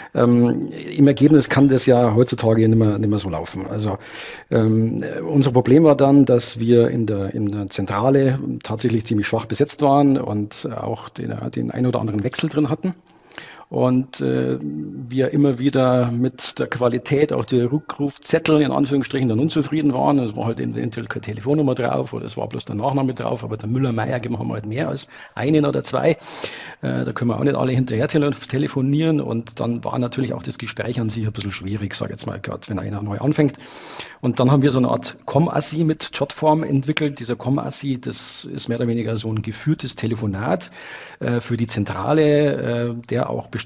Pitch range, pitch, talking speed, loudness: 110-140 Hz, 125 Hz, 195 wpm, -20 LUFS